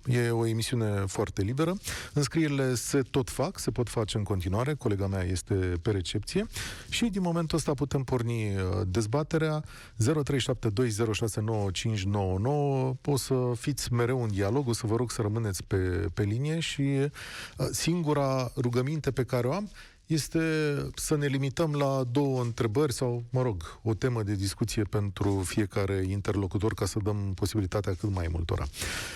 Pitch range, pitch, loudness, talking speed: 105-140 Hz, 120 Hz, -29 LUFS, 150 wpm